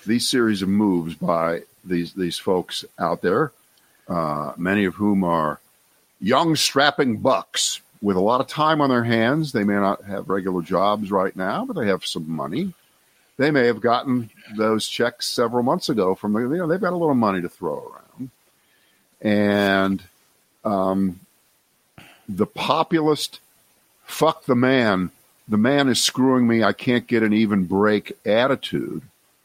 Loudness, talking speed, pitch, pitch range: -21 LUFS, 160 wpm, 110 Hz, 95-130 Hz